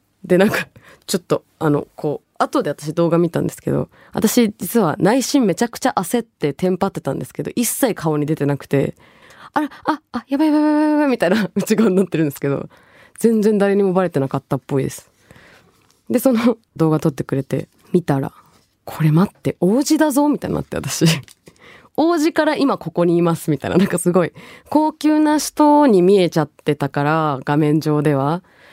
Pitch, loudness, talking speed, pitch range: 180 Hz, -18 LUFS, 370 characters per minute, 155-245 Hz